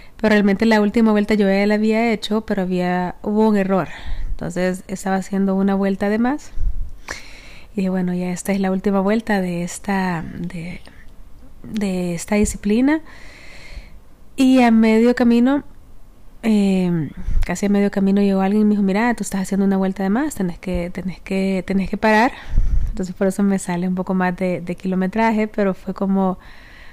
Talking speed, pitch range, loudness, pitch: 180 wpm, 185-215 Hz, -19 LUFS, 195 Hz